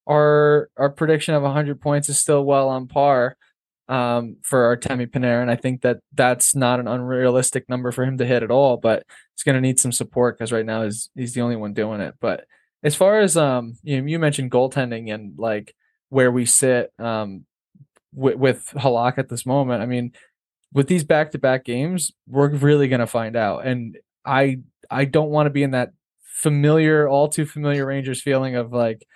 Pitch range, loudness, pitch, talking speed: 120-145 Hz, -20 LUFS, 130 Hz, 210 wpm